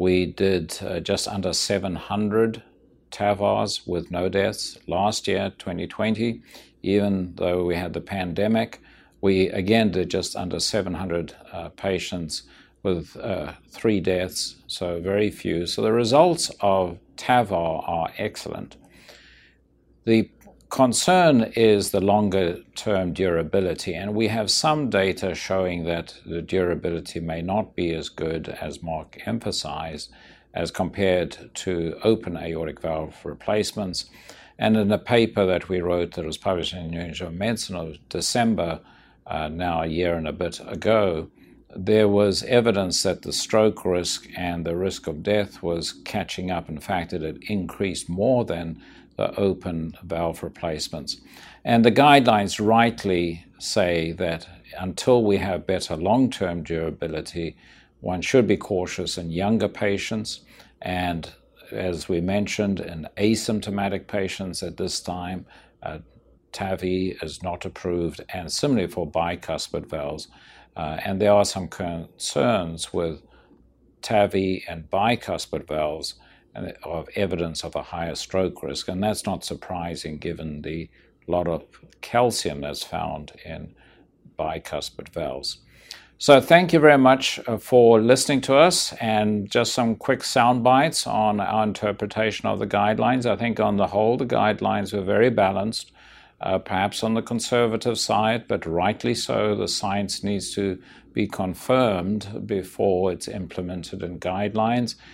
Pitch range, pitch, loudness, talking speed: 85-105 Hz, 95 Hz, -23 LUFS, 140 wpm